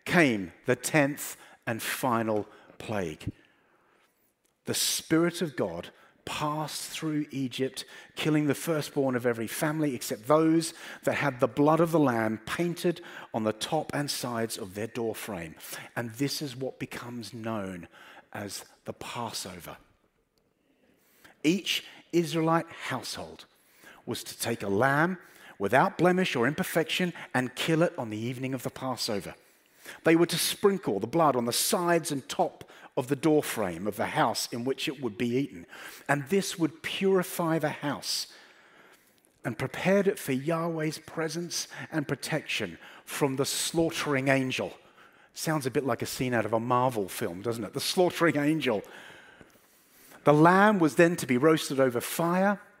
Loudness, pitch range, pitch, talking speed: -28 LUFS, 125-165 Hz, 145 Hz, 150 wpm